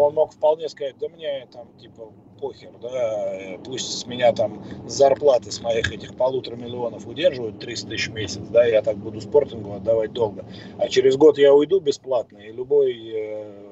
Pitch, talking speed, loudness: 120 Hz, 175 wpm, -21 LUFS